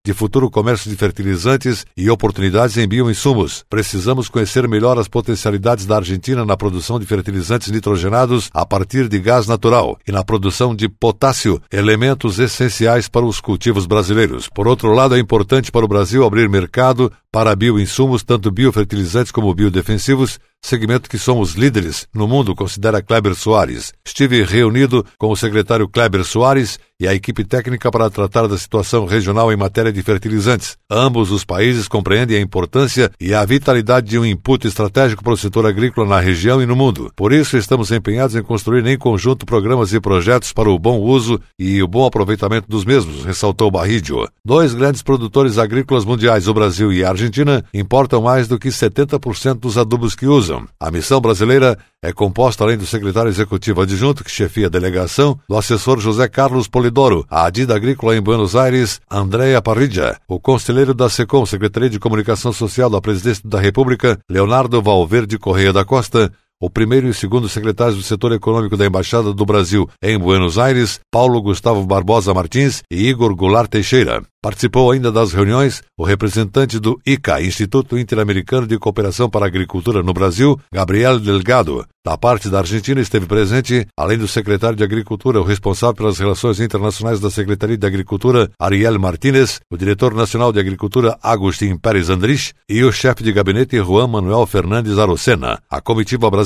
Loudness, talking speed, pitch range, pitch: -15 LUFS, 170 wpm, 100-125 Hz, 110 Hz